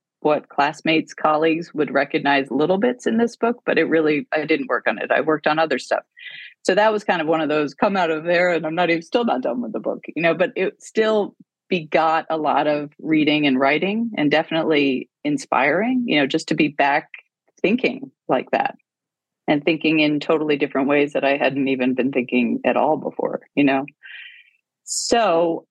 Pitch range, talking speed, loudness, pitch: 145-180 Hz, 205 wpm, -20 LUFS, 160 Hz